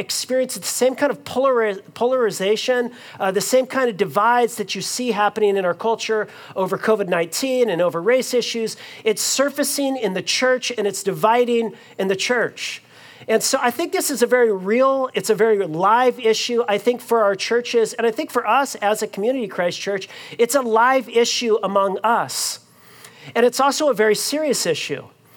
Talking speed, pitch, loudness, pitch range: 190 wpm, 230 Hz, -19 LUFS, 205-250 Hz